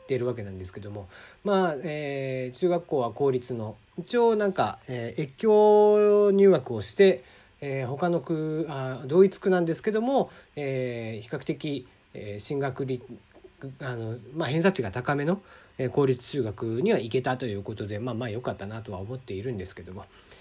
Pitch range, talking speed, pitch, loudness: 115-165 Hz, 335 characters per minute, 130 Hz, -26 LUFS